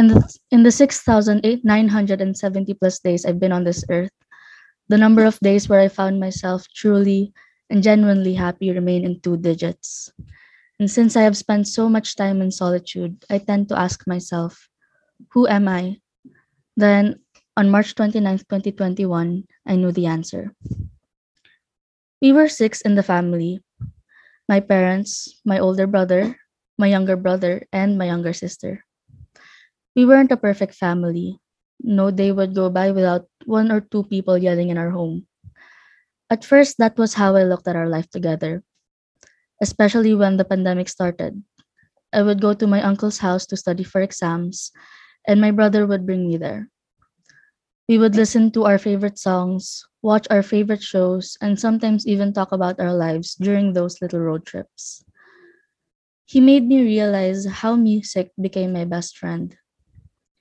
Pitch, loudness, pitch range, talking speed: 195 Hz, -18 LUFS, 180-215 Hz, 155 wpm